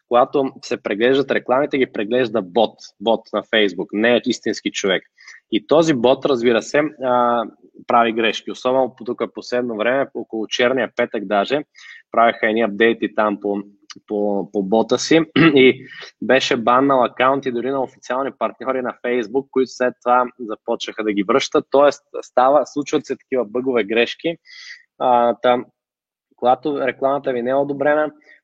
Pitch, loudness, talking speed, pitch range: 125 Hz, -18 LUFS, 150 wpm, 115-135 Hz